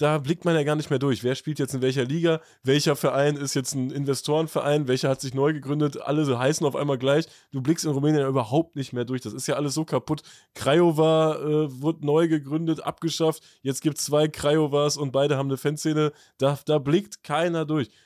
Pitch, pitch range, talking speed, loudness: 145 Hz, 135-155 Hz, 225 wpm, -24 LUFS